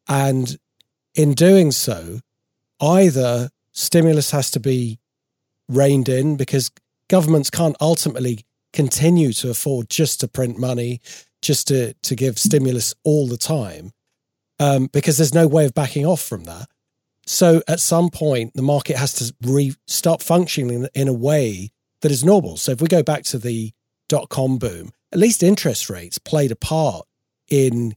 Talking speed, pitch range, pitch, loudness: 160 wpm, 125-155 Hz, 135 Hz, -18 LUFS